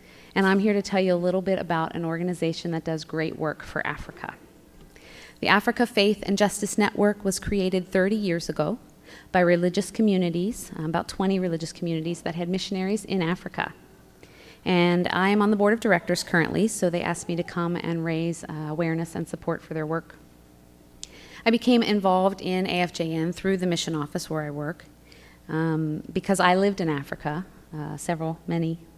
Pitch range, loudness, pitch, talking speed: 165-195 Hz, -25 LUFS, 175 Hz, 175 wpm